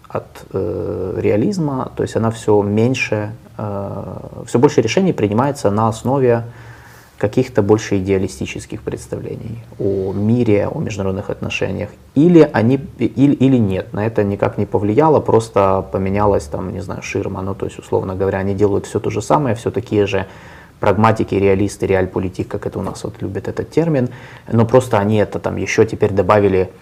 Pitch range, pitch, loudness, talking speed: 100-120 Hz, 105 Hz, -17 LUFS, 165 wpm